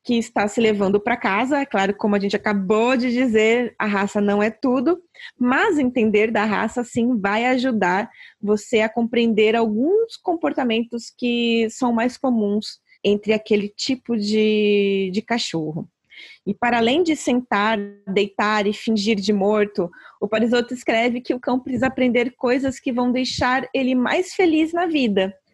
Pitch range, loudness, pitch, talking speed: 210-255 Hz, -20 LUFS, 230 Hz, 160 wpm